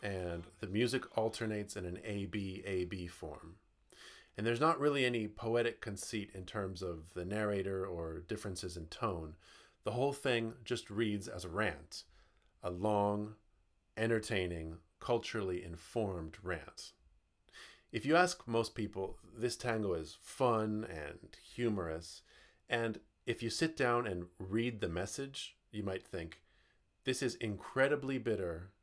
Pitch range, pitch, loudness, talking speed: 90-115 Hz, 105 Hz, -38 LUFS, 140 wpm